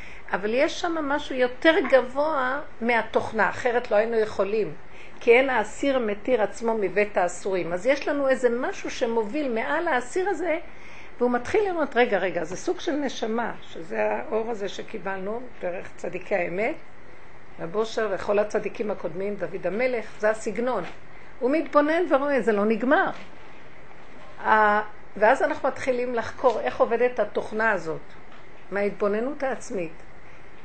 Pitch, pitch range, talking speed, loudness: 240 Hz, 210-280 Hz, 135 wpm, -25 LUFS